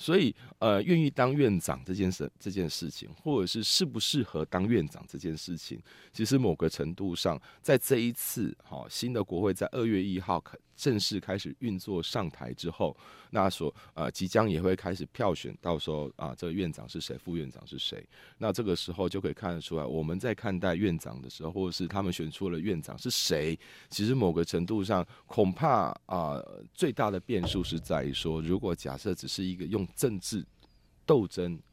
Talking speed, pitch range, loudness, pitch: 295 characters per minute, 80-105 Hz, -31 LUFS, 90 Hz